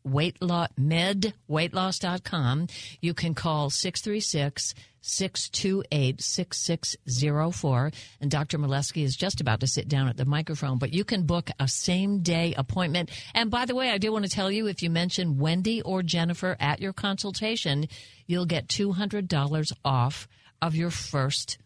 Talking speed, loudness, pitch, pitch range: 145 wpm, -27 LUFS, 160 Hz, 135-185 Hz